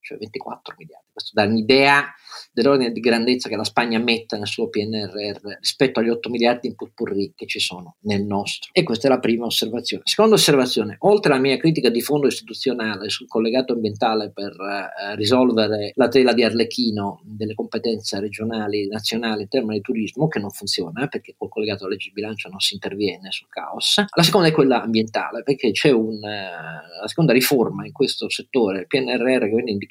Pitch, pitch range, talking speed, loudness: 115 Hz, 105-130 Hz, 195 wpm, -20 LUFS